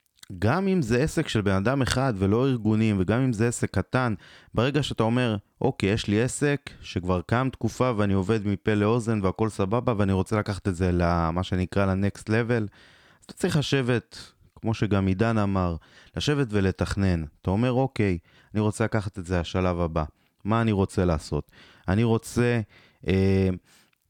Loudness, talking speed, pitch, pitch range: -25 LUFS, 165 wpm, 105 Hz, 95-120 Hz